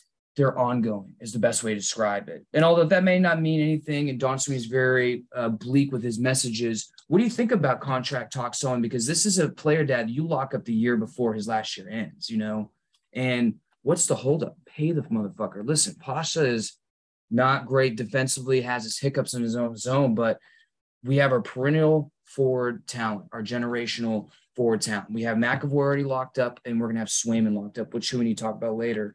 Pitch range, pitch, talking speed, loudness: 115-140 Hz, 125 Hz, 215 wpm, -25 LUFS